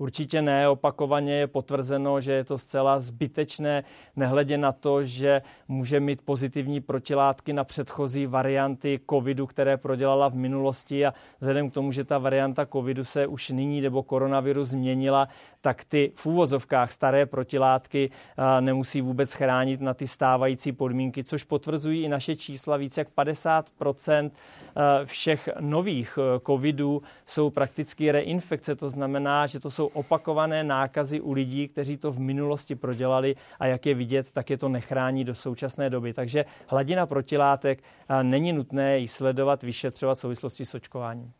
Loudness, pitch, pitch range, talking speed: -26 LUFS, 140 Hz, 135-145 Hz, 150 wpm